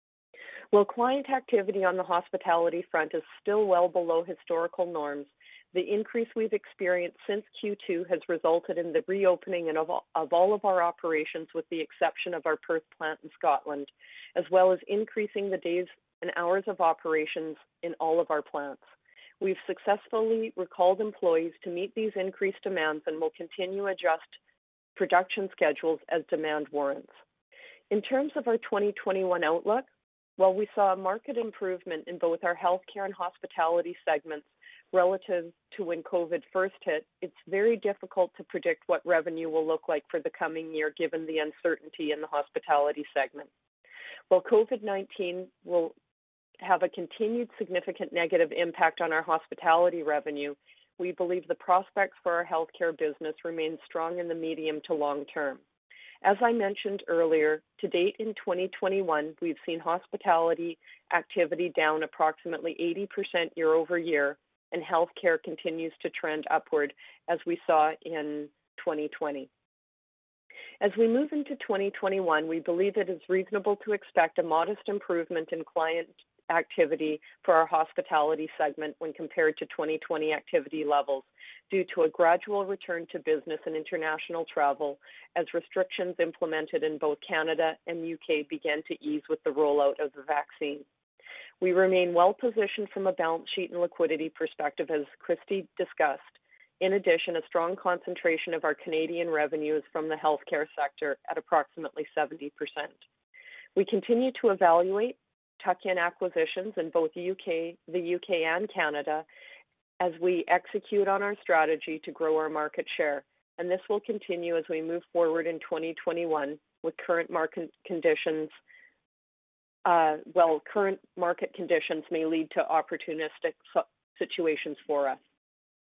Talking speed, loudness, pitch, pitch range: 150 wpm, -29 LUFS, 170 Hz, 160-195 Hz